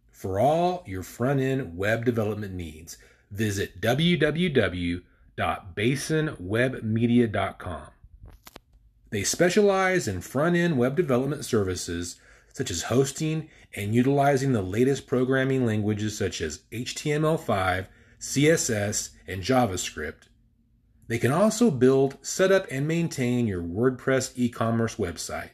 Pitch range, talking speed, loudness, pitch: 105-140 Hz, 110 wpm, -25 LUFS, 120 Hz